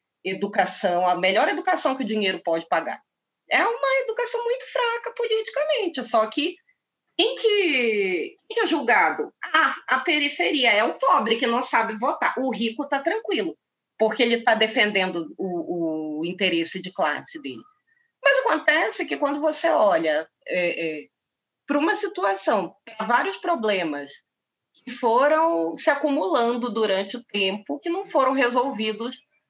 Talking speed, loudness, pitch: 145 wpm, -23 LUFS, 260 Hz